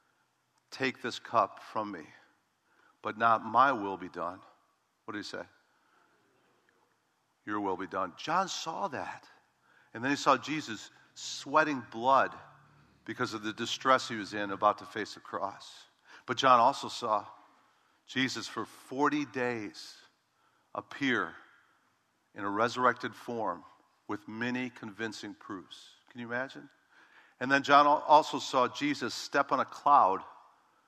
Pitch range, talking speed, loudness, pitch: 110-135 Hz, 140 wpm, -31 LUFS, 125 Hz